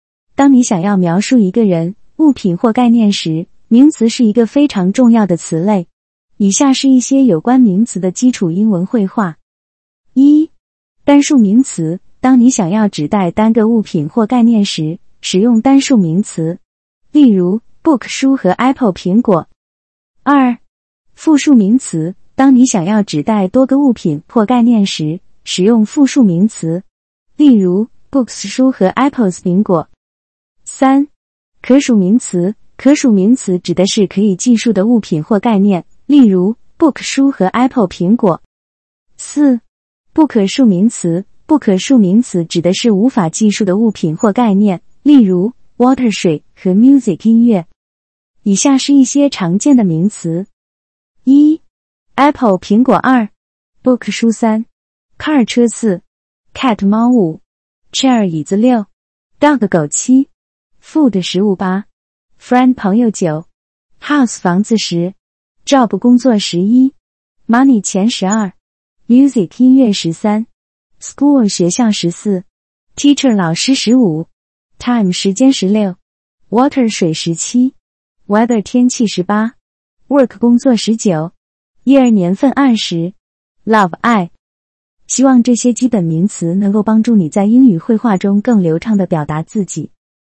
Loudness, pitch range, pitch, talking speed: -12 LUFS, 185-250 Hz, 215 Hz, 260 characters per minute